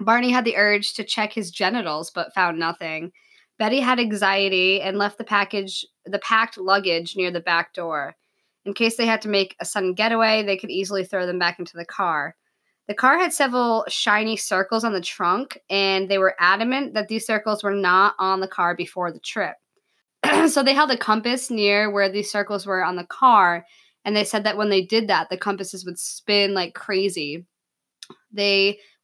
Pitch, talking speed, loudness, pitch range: 200 Hz, 195 wpm, -21 LUFS, 185-220 Hz